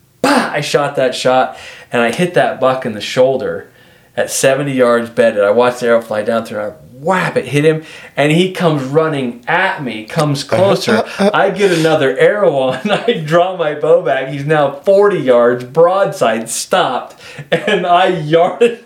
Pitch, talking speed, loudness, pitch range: 150 Hz, 180 wpm, -13 LUFS, 125-180 Hz